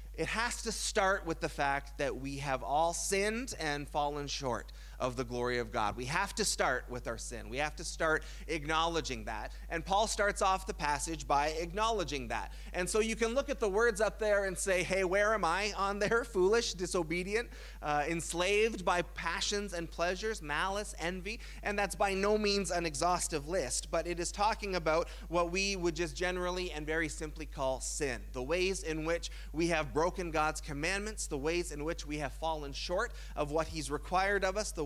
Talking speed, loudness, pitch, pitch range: 200 wpm, -34 LUFS, 170 Hz, 150-200 Hz